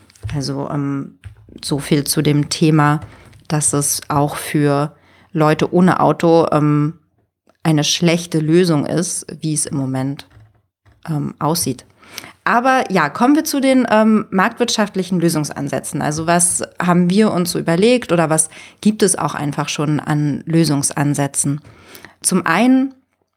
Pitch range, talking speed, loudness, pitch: 145-180 Hz, 135 wpm, -16 LUFS, 155 Hz